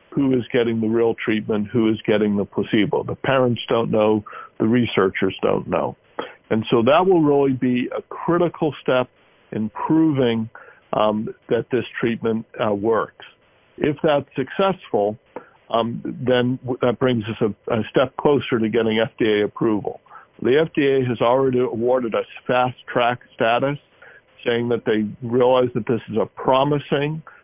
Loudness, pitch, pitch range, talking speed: -20 LUFS, 125 Hz, 110-135 Hz, 155 wpm